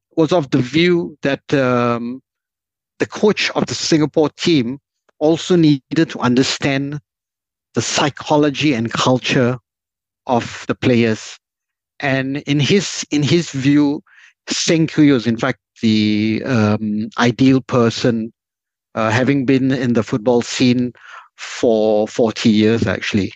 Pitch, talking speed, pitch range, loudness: 130 Hz, 125 wpm, 115-150 Hz, -16 LUFS